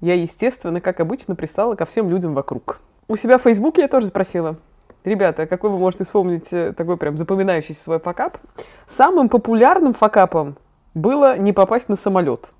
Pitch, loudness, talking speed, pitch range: 190 Hz, -18 LUFS, 160 wpm, 170-230 Hz